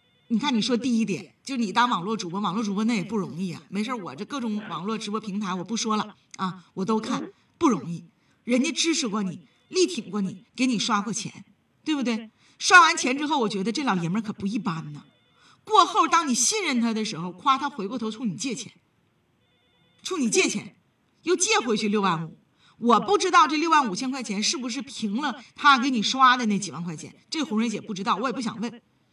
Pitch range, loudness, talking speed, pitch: 200-270 Hz, -24 LUFS, 310 characters per minute, 225 Hz